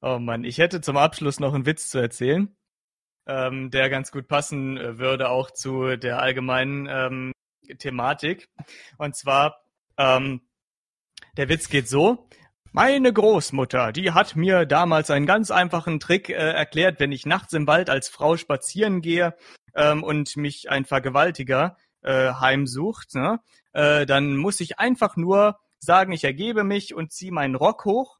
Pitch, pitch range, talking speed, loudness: 150 Hz, 135-175 Hz, 155 wpm, -22 LUFS